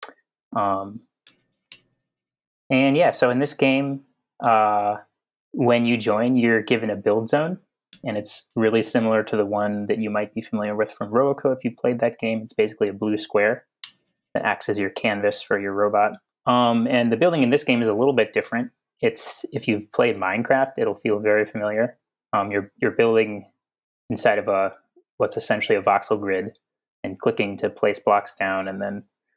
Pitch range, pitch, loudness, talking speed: 105-130 Hz, 110 Hz, -22 LUFS, 185 wpm